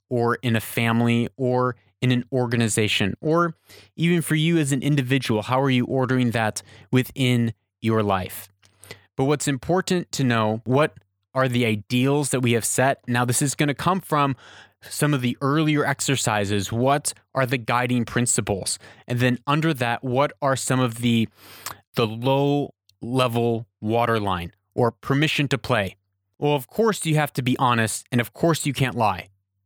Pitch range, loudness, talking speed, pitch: 110-140 Hz, -22 LUFS, 170 wpm, 125 Hz